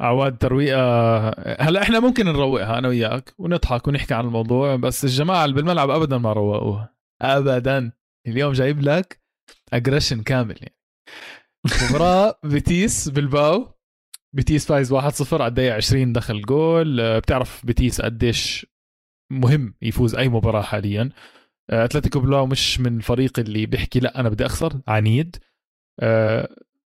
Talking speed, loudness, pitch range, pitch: 130 wpm, -20 LUFS, 115-145 Hz, 130 Hz